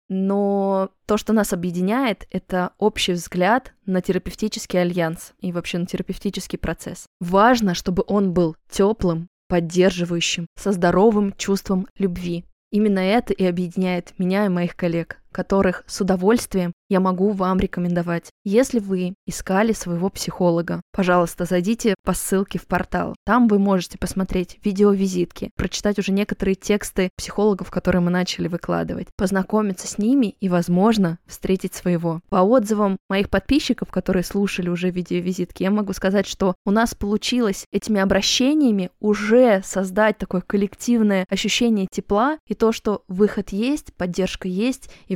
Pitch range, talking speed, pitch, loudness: 180-210 Hz, 140 wpm, 195 Hz, -21 LUFS